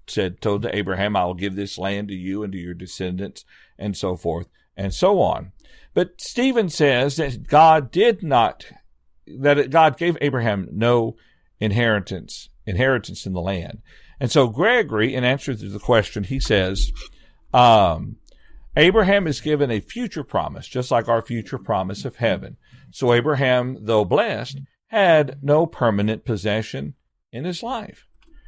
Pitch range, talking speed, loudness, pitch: 100-145 Hz, 155 wpm, -20 LUFS, 115 Hz